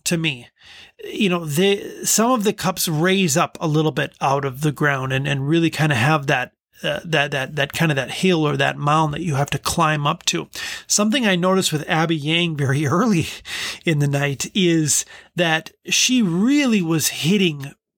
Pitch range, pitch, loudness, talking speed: 145-185 Hz, 160 Hz, -19 LUFS, 205 wpm